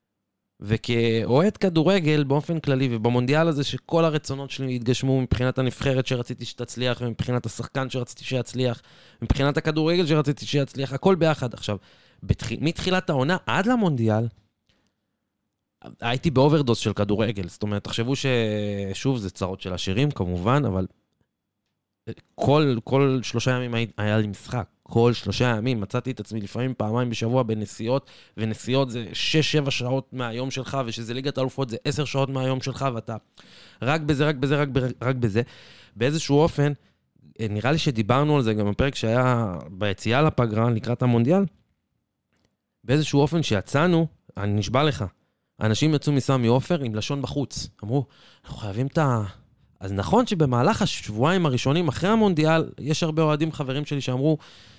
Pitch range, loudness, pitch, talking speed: 115-145 Hz, -24 LUFS, 130 Hz, 140 wpm